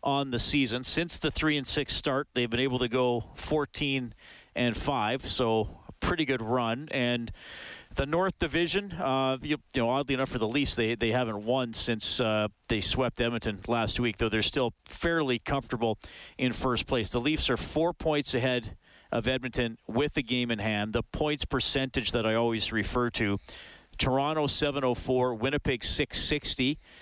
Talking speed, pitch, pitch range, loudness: 175 wpm, 125 Hz, 115-140 Hz, -28 LUFS